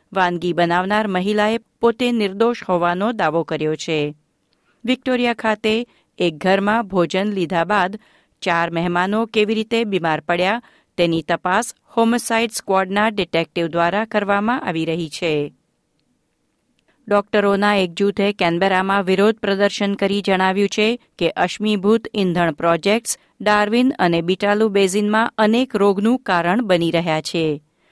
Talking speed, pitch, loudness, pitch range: 120 wpm, 200 Hz, -19 LUFS, 175-215 Hz